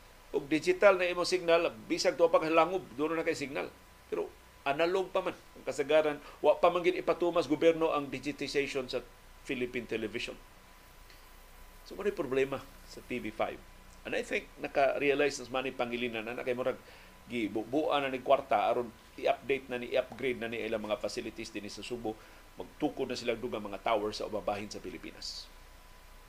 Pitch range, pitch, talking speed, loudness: 120-165 Hz, 140 Hz, 170 wpm, -32 LUFS